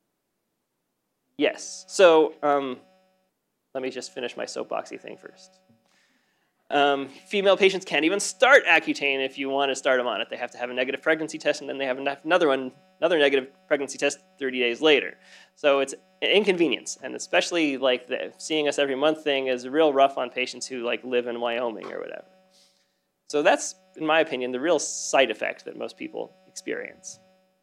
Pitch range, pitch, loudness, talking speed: 135-185 Hz, 150 Hz, -24 LUFS, 185 wpm